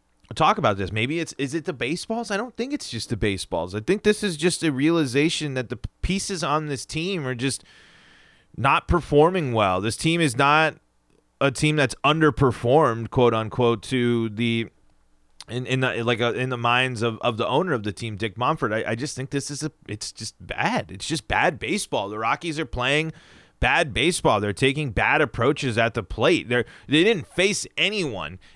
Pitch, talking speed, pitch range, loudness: 130 Hz, 200 wpm, 115-160 Hz, -23 LUFS